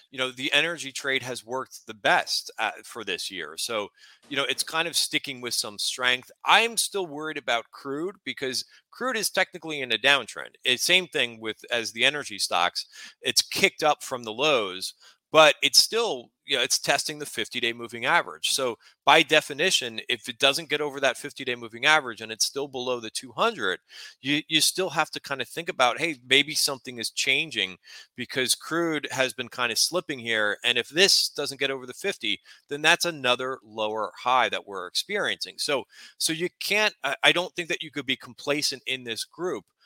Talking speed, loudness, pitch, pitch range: 200 wpm, -24 LUFS, 135 Hz, 125-155 Hz